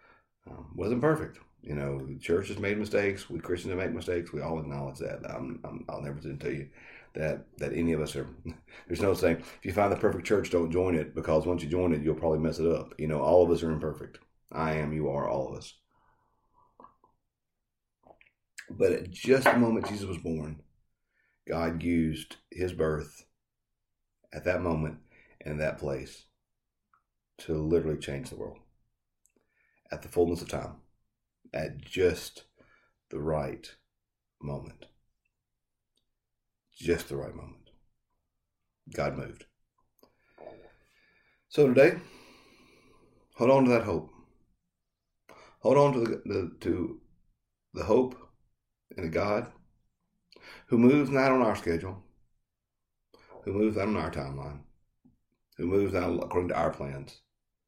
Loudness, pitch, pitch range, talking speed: -29 LUFS, 85 Hz, 75-105 Hz, 145 wpm